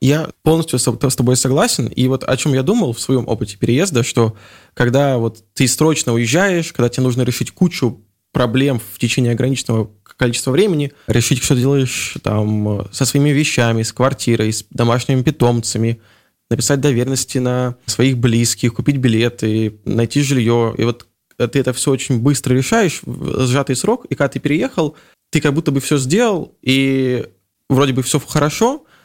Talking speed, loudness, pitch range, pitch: 165 wpm, -16 LUFS, 115-140 Hz, 130 Hz